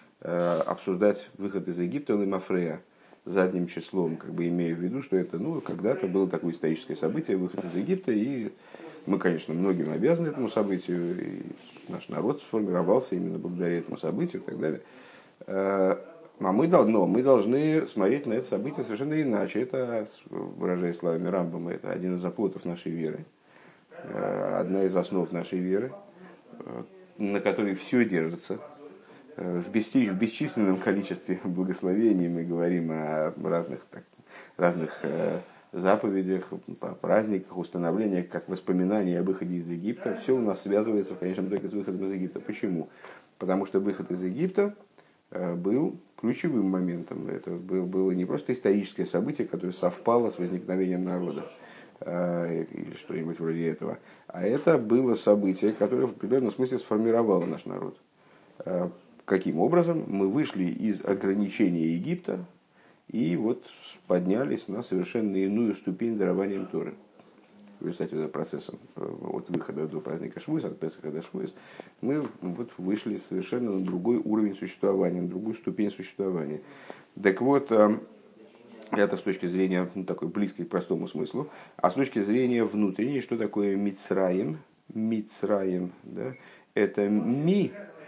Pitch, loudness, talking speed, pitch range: 95 Hz, -28 LUFS, 140 wpm, 90-105 Hz